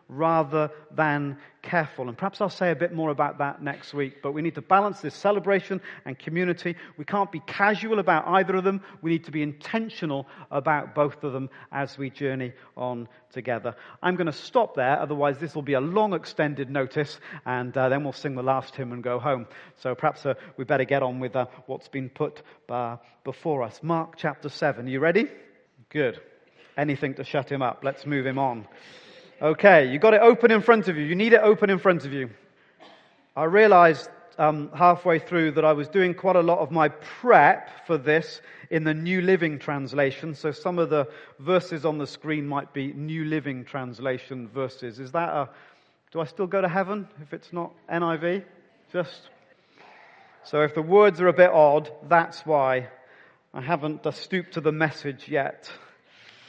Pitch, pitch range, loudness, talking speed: 155 Hz, 140-175 Hz, -24 LUFS, 195 wpm